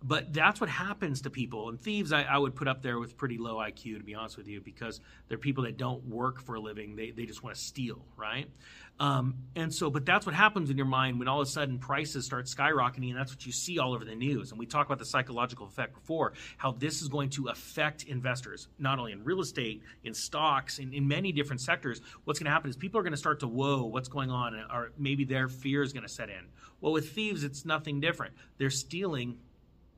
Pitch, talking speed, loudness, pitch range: 135 Hz, 250 wpm, -32 LUFS, 125-150 Hz